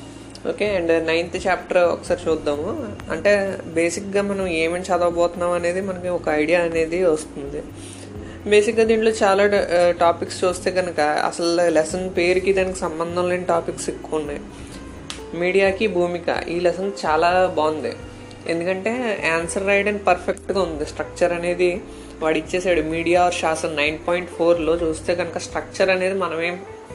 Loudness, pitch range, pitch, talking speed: -21 LUFS, 165-185 Hz, 175 Hz, 130 wpm